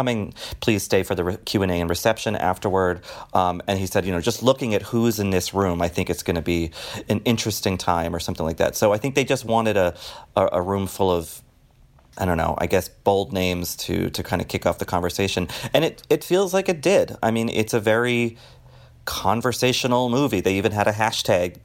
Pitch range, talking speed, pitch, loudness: 90-120 Hz, 230 wpm, 100 Hz, -22 LUFS